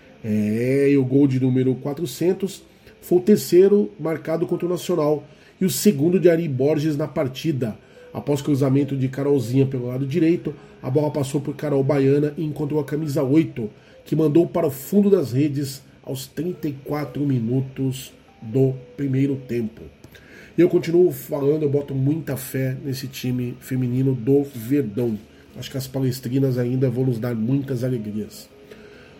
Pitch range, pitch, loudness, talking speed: 130-155 Hz, 140 Hz, -22 LUFS, 155 wpm